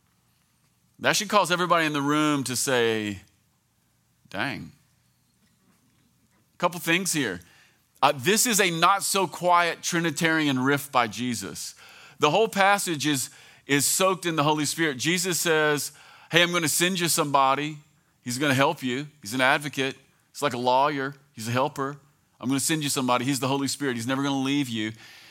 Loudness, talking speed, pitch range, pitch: -24 LUFS, 180 wpm, 135-170 Hz, 145 Hz